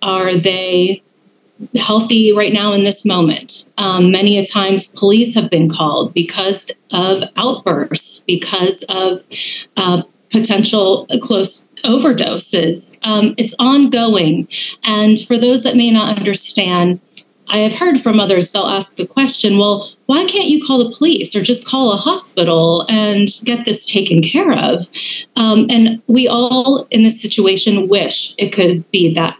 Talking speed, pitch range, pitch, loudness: 150 wpm, 190-235 Hz, 210 Hz, -12 LUFS